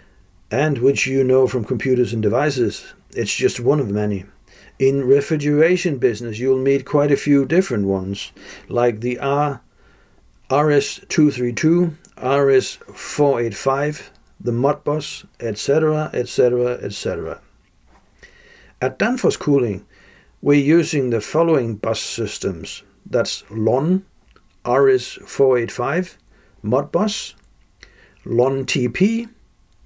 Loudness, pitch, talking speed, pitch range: -19 LUFS, 135 Hz, 90 wpm, 120-150 Hz